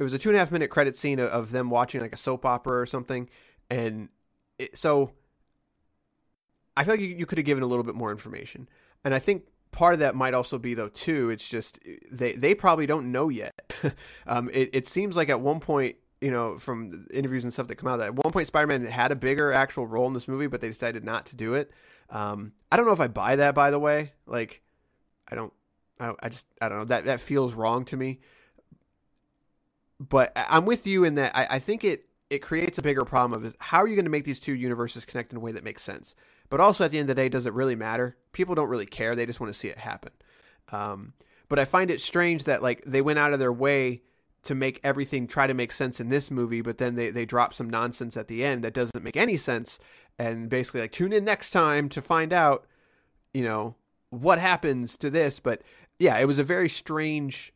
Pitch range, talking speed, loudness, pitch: 120-145 Hz, 245 wpm, -26 LUFS, 130 Hz